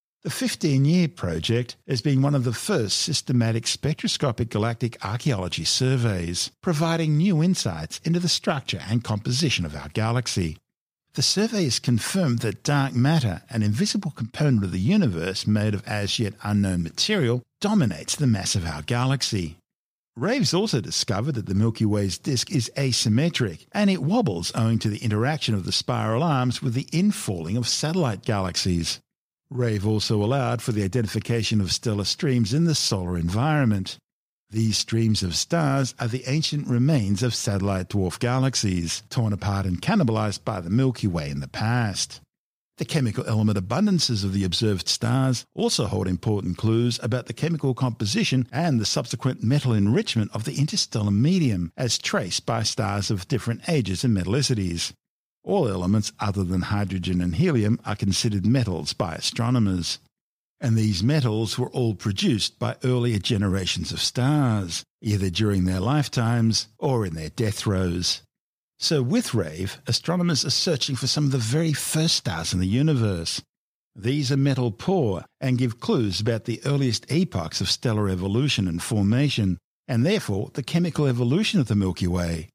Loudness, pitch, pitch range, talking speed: -24 LUFS, 115 Hz, 100-135 Hz, 160 wpm